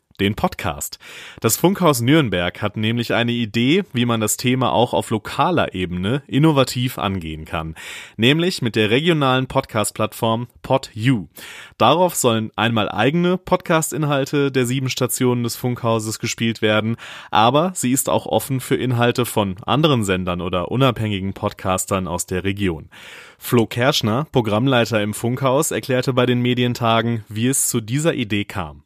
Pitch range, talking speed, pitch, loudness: 105-130 Hz, 145 wpm, 120 Hz, -19 LUFS